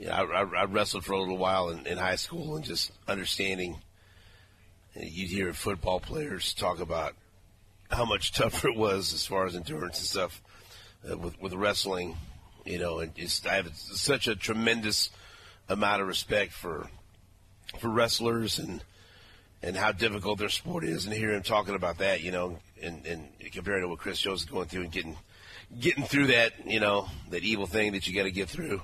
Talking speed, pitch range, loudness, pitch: 195 wpm, 90-105 Hz, -30 LUFS, 95 Hz